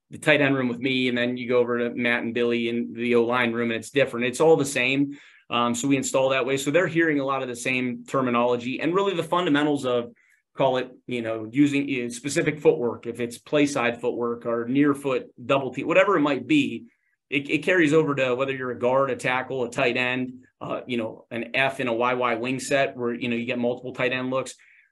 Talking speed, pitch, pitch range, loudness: 240 wpm, 125 Hz, 120-140 Hz, -24 LUFS